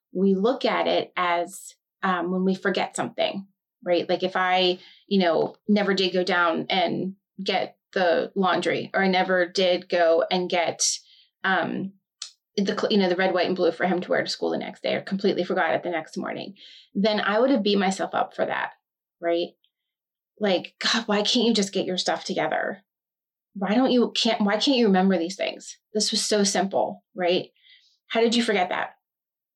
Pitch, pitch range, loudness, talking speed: 195 Hz, 180-220 Hz, -24 LUFS, 195 wpm